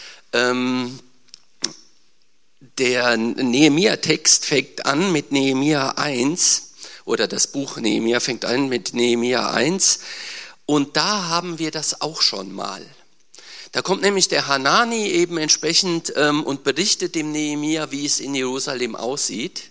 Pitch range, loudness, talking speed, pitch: 125-165 Hz, -19 LUFS, 120 wpm, 145 Hz